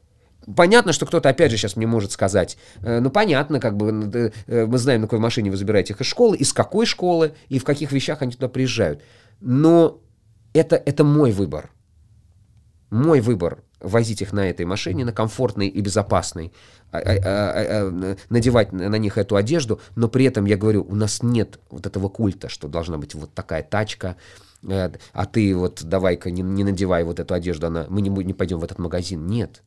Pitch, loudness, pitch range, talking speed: 105 Hz, -20 LUFS, 95-120 Hz, 190 wpm